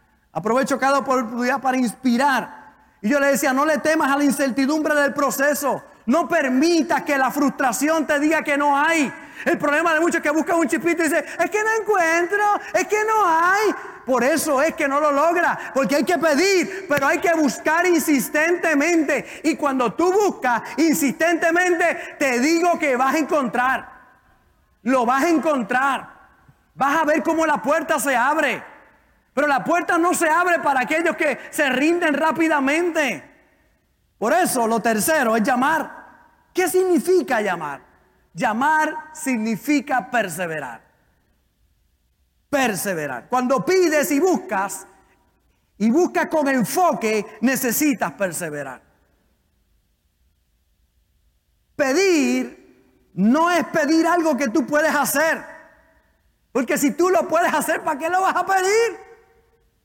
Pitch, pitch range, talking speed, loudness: 300 Hz, 260-330 Hz, 140 wpm, -19 LUFS